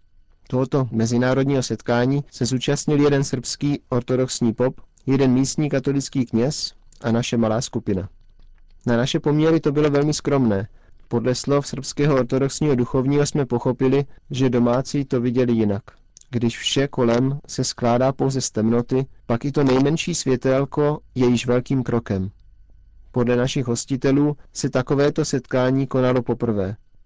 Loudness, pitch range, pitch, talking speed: -21 LUFS, 120-140 Hz, 130 Hz, 135 wpm